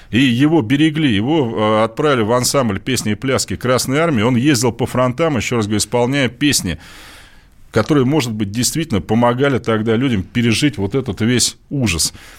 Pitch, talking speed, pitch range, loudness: 120 Hz, 160 wpm, 110-140 Hz, -16 LUFS